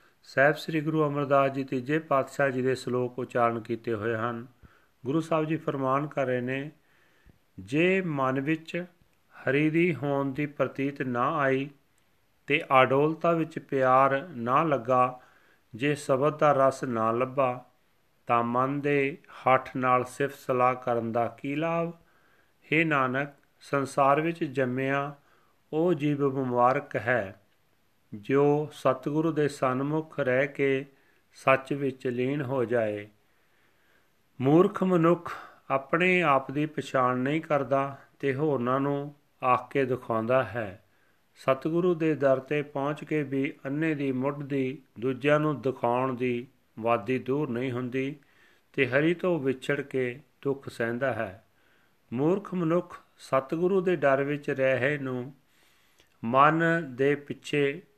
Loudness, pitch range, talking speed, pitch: -27 LUFS, 125-150 Hz, 130 wpm, 135 Hz